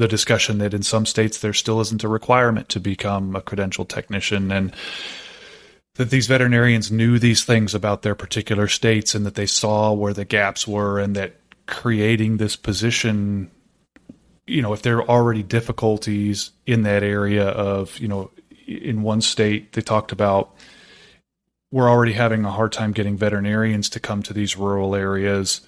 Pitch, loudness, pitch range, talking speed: 105 Hz, -20 LUFS, 100-115 Hz, 170 wpm